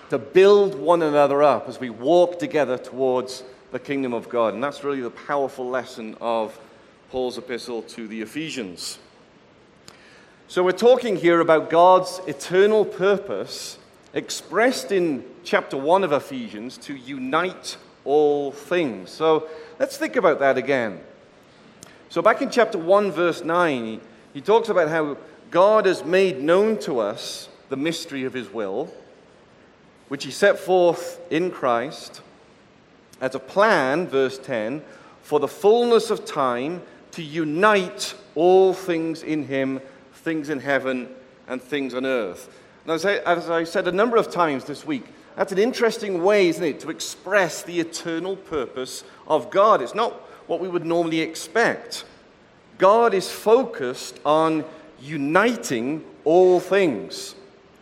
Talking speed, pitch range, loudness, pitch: 145 wpm, 135-195 Hz, -21 LUFS, 165 Hz